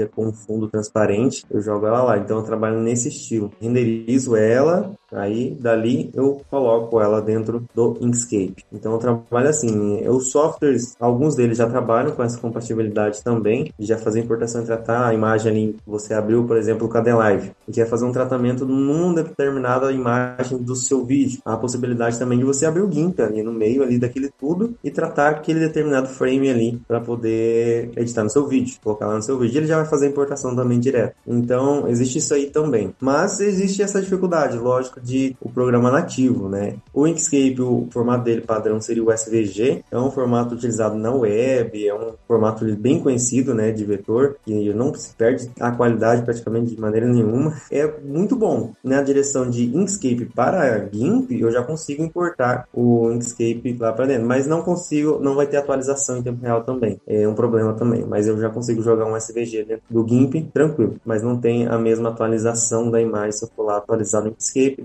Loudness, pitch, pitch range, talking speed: -20 LUFS, 120 Hz, 115-135 Hz, 195 wpm